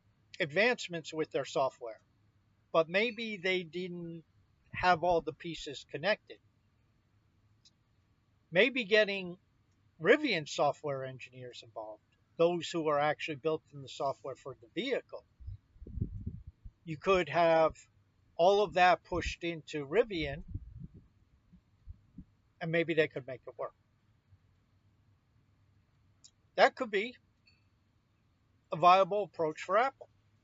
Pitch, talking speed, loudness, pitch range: 120 Hz, 105 wpm, -32 LUFS, 105-170 Hz